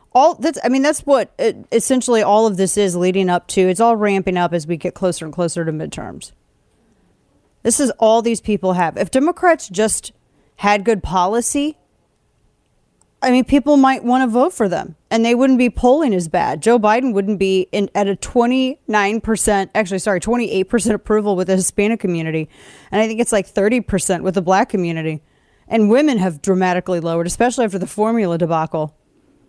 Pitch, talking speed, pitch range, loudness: 210 Hz, 185 wpm, 185-240 Hz, -17 LUFS